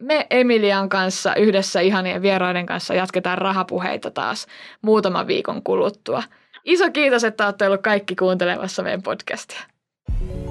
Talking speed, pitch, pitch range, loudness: 125 wpm, 195 Hz, 185-225 Hz, -20 LUFS